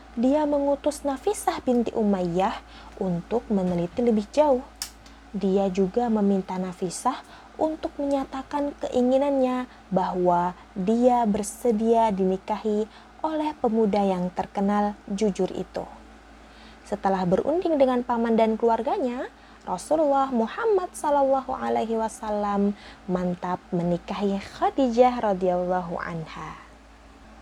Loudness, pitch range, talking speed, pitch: -25 LUFS, 190-265 Hz, 90 wpm, 225 Hz